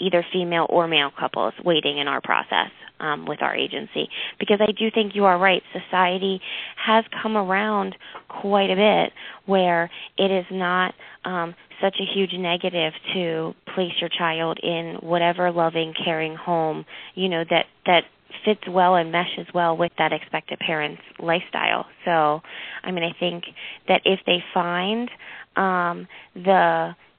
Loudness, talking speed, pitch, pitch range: -22 LUFS, 155 wpm, 175 Hz, 165-190 Hz